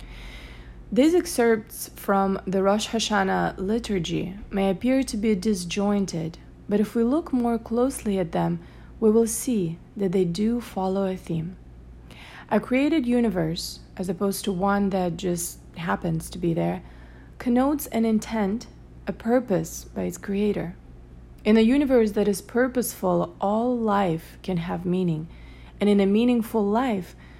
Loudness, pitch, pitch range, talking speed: -24 LUFS, 200 Hz, 175-225 Hz, 145 wpm